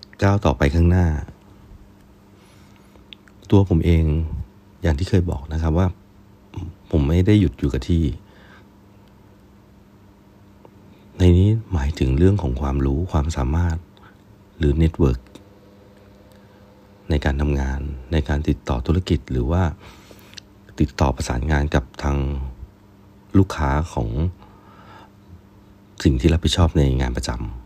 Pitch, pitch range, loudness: 95 Hz, 80-100 Hz, -21 LUFS